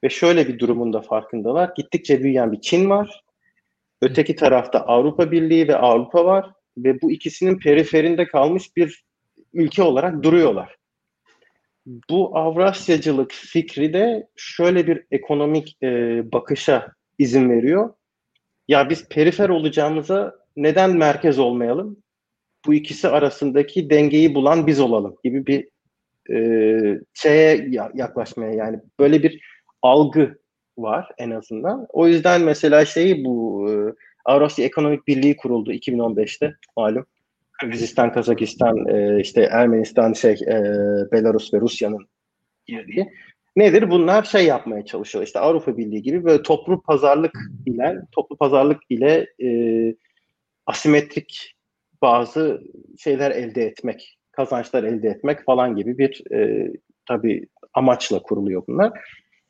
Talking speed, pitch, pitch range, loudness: 120 wpm, 150 Hz, 120-170 Hz, -18 LUFS